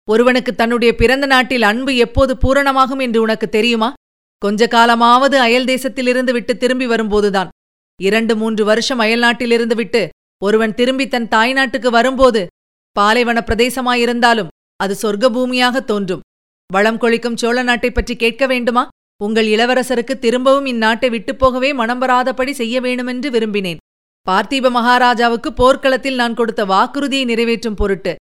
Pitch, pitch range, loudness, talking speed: 240 Hz, 225-255 Hz, -14 LUFS, 125 wpm